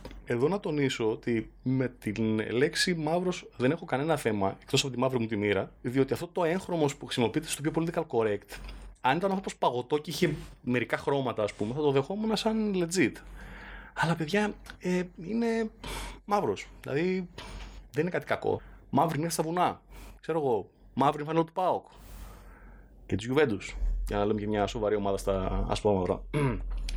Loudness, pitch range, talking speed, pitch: -30 LUFS, 105-170 Hz, 170 wpm, 135 Hz